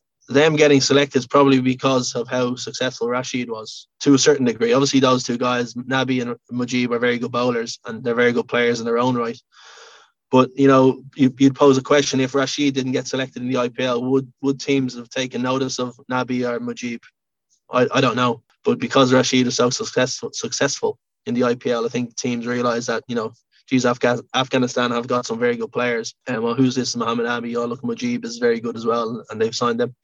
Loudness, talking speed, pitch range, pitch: -20 LUFS, 220 wpm, 120-135 Hz, 125 Hz